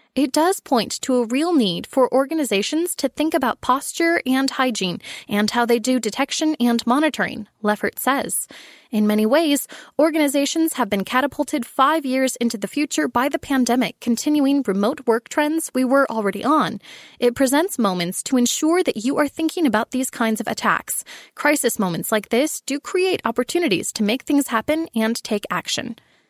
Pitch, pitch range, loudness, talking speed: 260 Hz, 230-300 Hz, -20 LUFS, 170 wpm